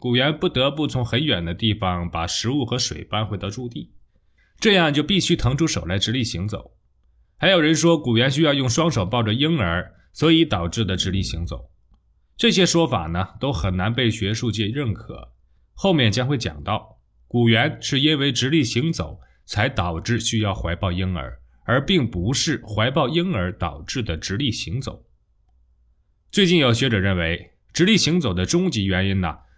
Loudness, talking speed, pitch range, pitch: -21 LUFS, 260 characters per minute, 90-140 Hz, 110 Hz